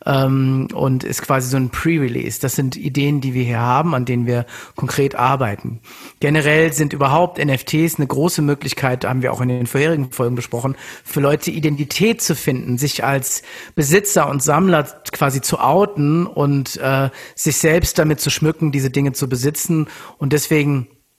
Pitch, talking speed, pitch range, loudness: 140 Hz, 165 wpm, 135-155 Hz, -17 LUFS